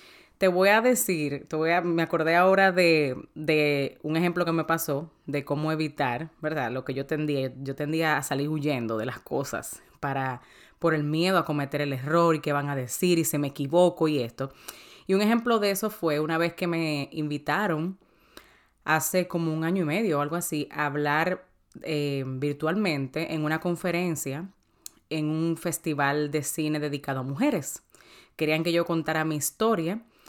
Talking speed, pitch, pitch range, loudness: 185 wpm, 155 Hz, 145-170 Hz, -26 LUFS